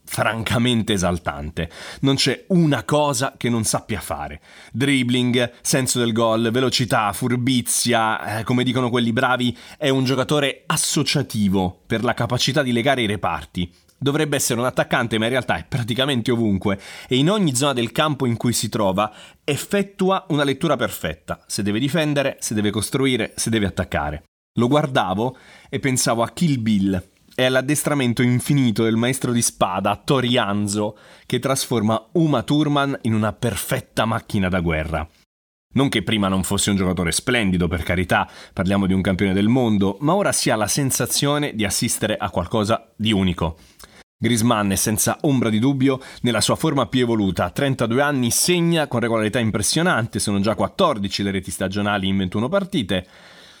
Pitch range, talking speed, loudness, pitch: 100-135 Hz, 160 wpm, -20 LUFS, 120 Hz